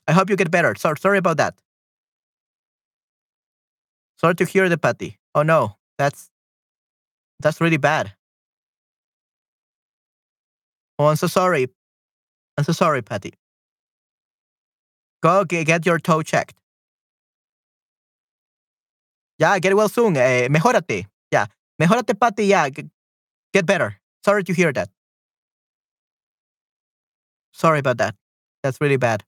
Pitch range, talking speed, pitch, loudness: 145-195 Hz, 115 wpm, 165 Hz, -19 LUFS